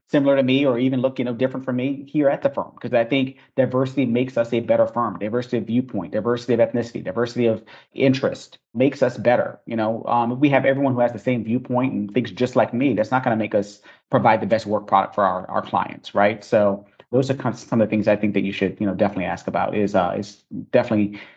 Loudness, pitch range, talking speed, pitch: -21 LUFS, 105-130 Hz, 255 wpm, 120 Hz